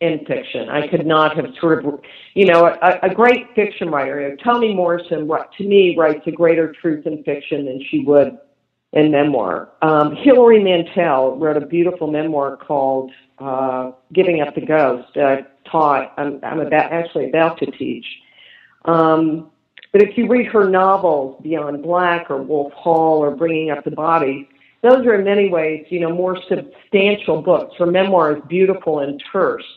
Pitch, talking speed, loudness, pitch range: 160 Hz, 180 wpm, -16 LUFS, 145-180 Hz